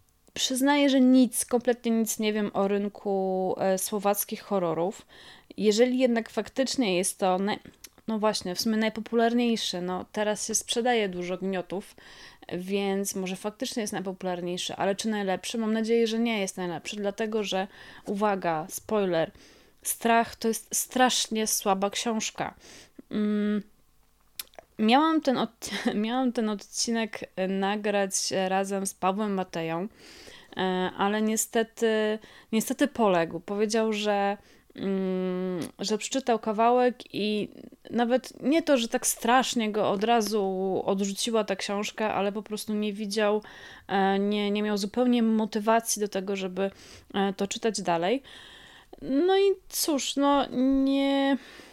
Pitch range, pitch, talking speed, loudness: 195-235 Hz, 215 Hz, 125 wpm, -27 LUFS